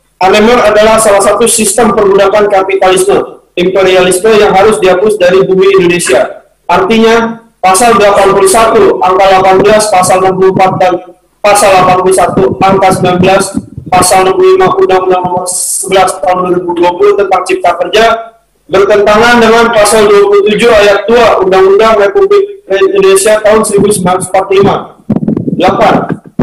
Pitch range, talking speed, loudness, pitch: 185-215 Hz, 105 wpm, -6 LUFS, 195 Hz